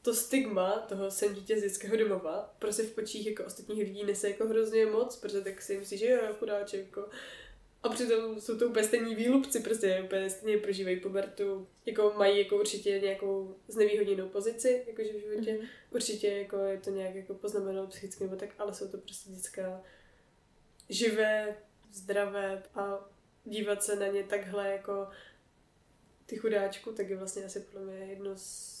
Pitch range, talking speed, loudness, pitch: 195-220 Hz, 170 wpm, -33 LUFS, 205 Hz